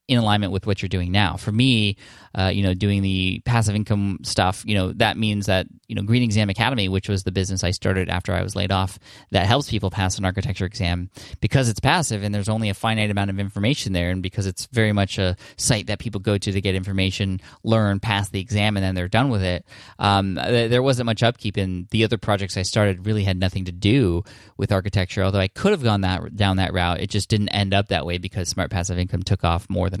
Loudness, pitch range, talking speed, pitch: -22 LUFS, 95-110 Hz, 245 wpm, 100 Hz